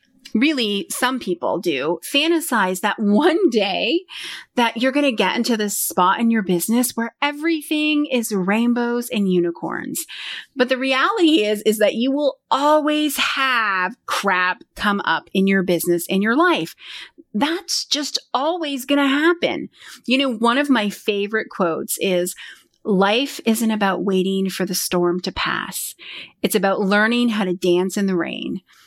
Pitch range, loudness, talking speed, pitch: 195-280 Hz, -19 LUFS, 160 wpm, 230 Hz